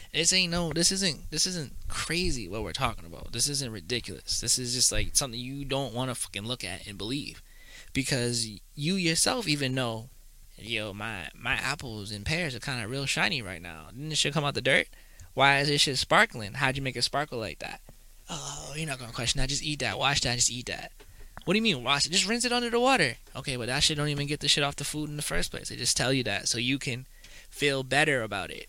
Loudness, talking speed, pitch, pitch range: -27 LUFS, 250 wpm, 130 Hz, 115-145 Hz